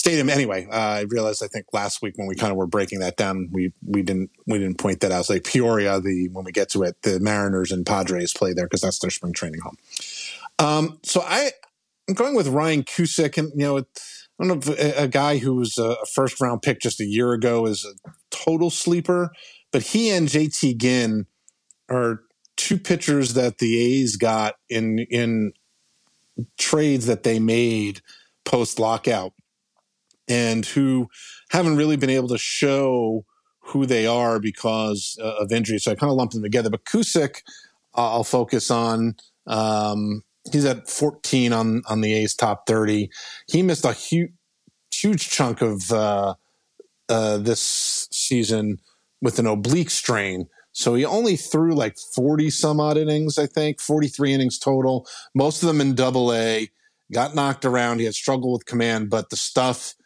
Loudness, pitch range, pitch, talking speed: -22 LUFS, 110-150 Hz, 120 Hz, 180 wpm